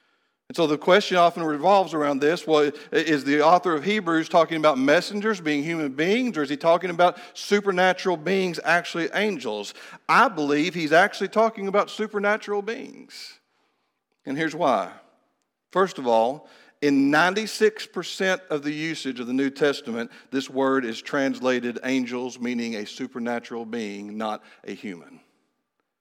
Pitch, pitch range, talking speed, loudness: 155 Hz, 135-195 Hz, 150 wpm, -23 LUFS